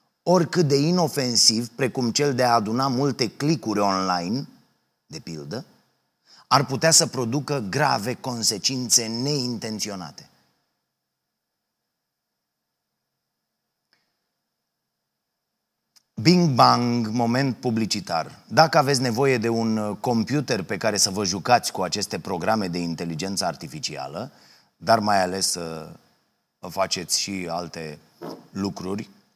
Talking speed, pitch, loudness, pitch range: 100 wpm, 115 Hz, -22 LUFS, 95-135 Hz